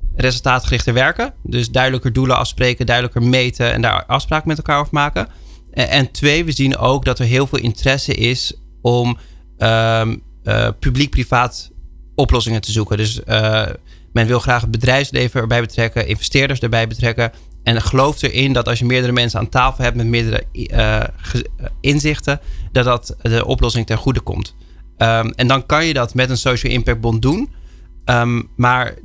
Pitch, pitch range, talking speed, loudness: 120 Hz, 115-130 Hz, 165 wpm, -16 LUFS